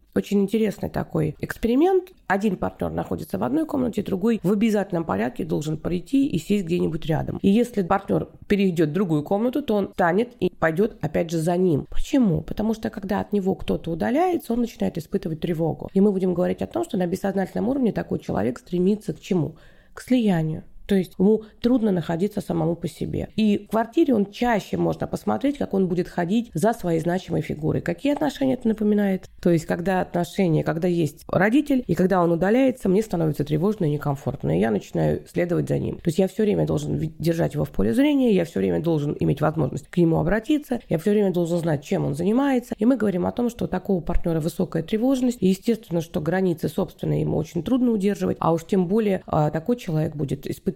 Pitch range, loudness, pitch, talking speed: 170-220 Hz, -23 LUFS, 190 Hz, 200 wpm